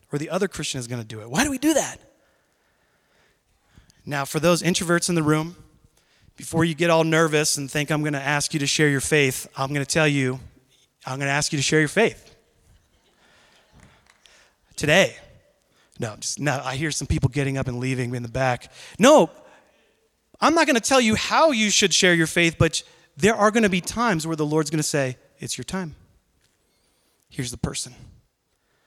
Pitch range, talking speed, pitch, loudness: 135-170 Hz, 190 wpm, 150 Hz, -21 LUFS